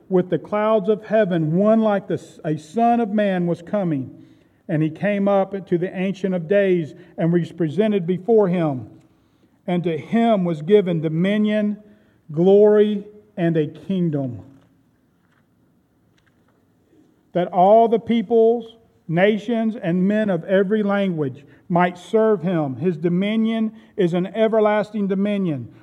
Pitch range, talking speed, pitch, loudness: 170-210 Hz, 130 wpm, 195 Hz, -20 LUFS